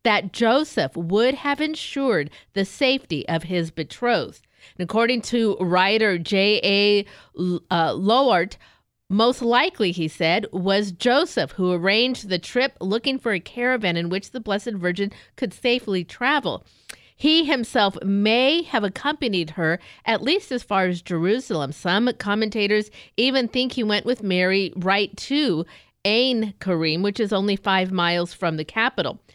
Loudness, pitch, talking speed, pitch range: -22 LUFS, 205 Hz, 145 wpm, 180-245 Hz